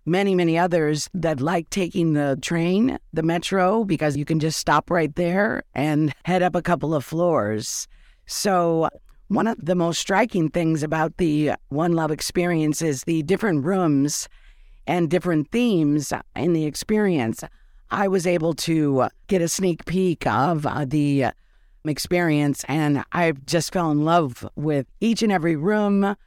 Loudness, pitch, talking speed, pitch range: -22 LUFS, 165 Hz, 155 wpm, 150-180 Hz